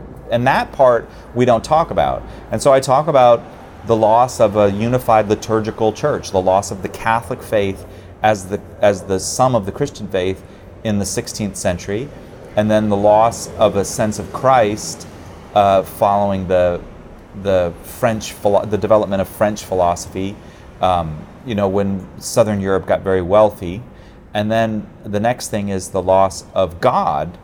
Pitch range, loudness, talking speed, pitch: 95-110 Hz, -17 LUFS, 170 wpm, 105 Hz